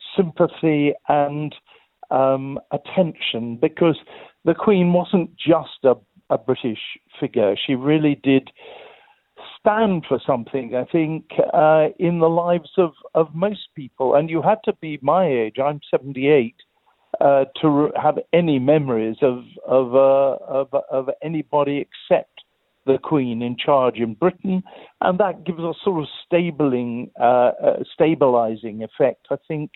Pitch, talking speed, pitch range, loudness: 150 Hz, 140 wpm, 135-170 Hz, -20 LUFS